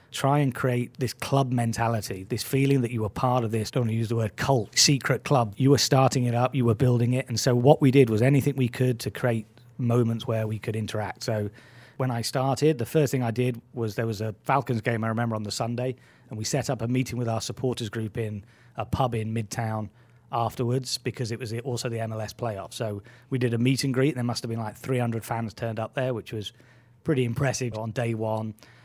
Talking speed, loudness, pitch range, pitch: 235 wpm, -26 LUFS, 115-130 Hz, 120 Hz